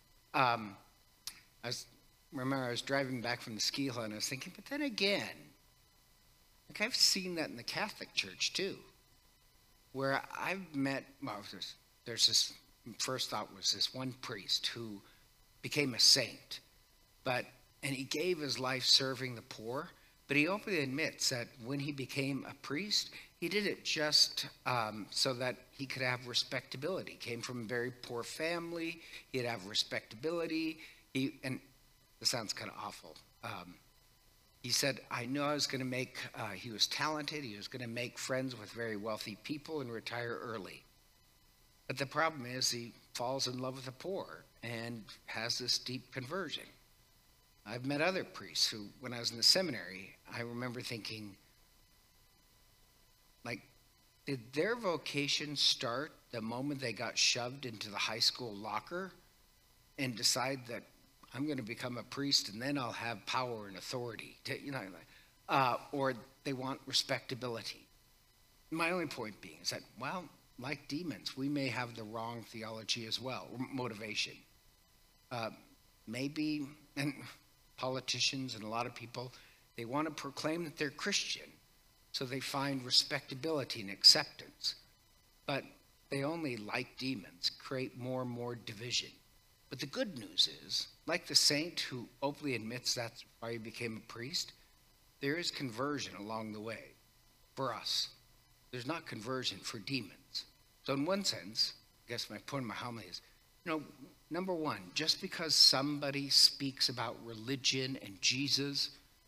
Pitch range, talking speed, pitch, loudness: 115-140 Hz, 160 wpm, 130 Hz, -35 LUFS